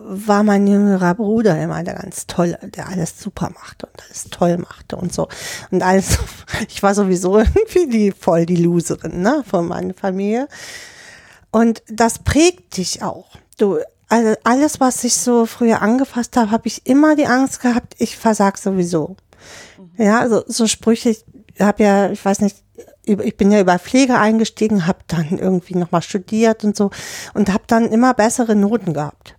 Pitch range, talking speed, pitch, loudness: 185-230 Hz, 175 wpm, 210 Hz, -16 LUFS